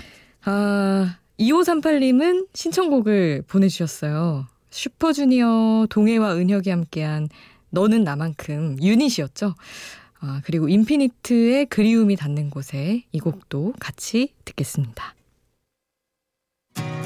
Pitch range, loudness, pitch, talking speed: 155-240 Hz, -21 LUFS, 200 Hz, 240 characters per minute